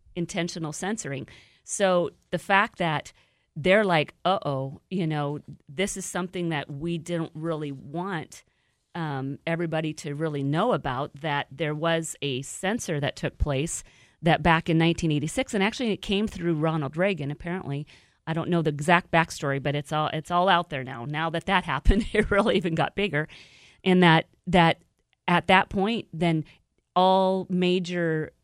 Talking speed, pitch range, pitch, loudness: 165 wpm, 150-185 Hz, 165 Hz, -26 LUFS